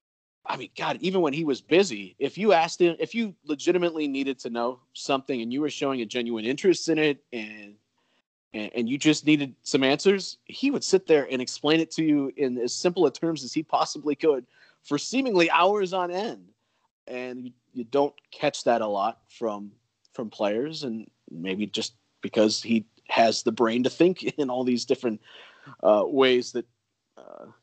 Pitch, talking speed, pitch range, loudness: 135 Hz, 190 wpm, 115-160 Hz, -25 LUFS